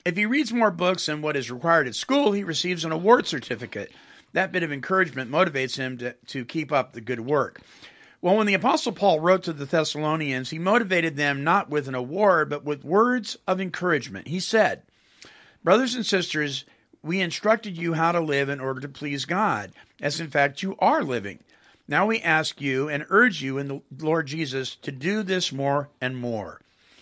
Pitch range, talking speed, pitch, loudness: 140-190 Hz, 200 wpm, 160 Hz, -24 LUFS